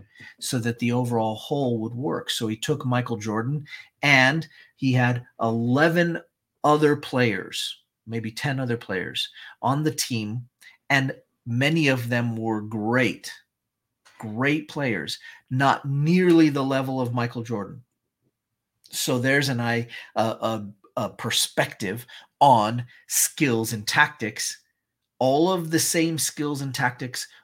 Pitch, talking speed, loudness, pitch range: 125 Hz, 125 wpm, -24 LUFS, 115-145 Hz